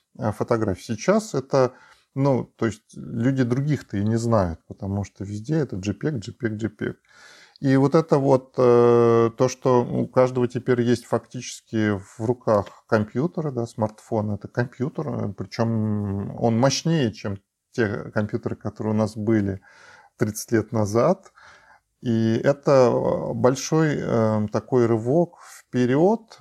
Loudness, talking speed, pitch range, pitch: -23 LUFS, 130 wpm, 110-130 Hz, 120 Hz